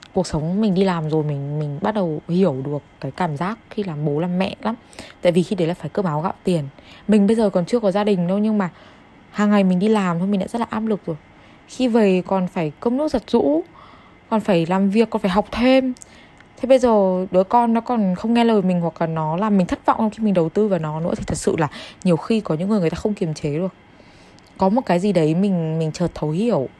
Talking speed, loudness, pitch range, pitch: 270 wpm, -20 LUFS, 165-215 Hz, 190 Hz